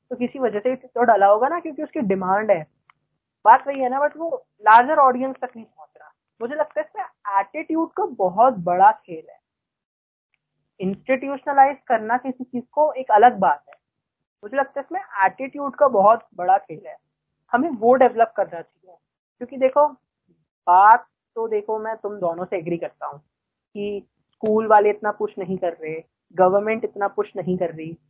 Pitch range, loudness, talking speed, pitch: 200-275 Hz, -20 LUFS, 180 wpm, 230 Hz